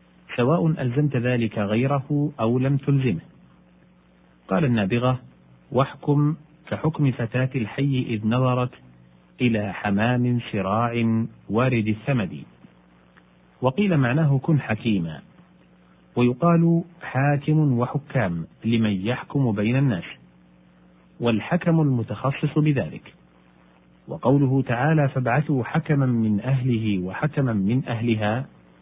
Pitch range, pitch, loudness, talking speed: 95-140 Hz, 120 Hz, -23 LUFS, 90 wpm